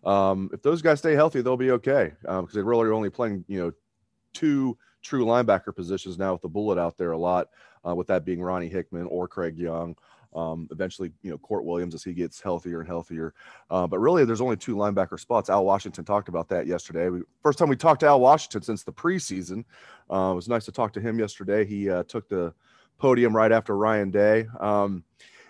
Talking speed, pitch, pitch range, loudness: 220 wpm, 100 Hz, 90-115 Hz, -25 LUFS